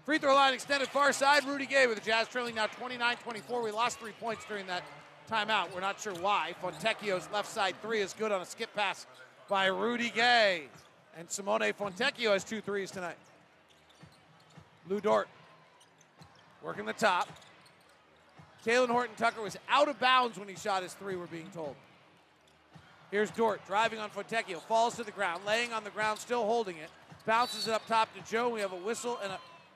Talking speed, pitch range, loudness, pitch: 190 wpm, 190-235 Hz, -31 LUFS, 215 Hz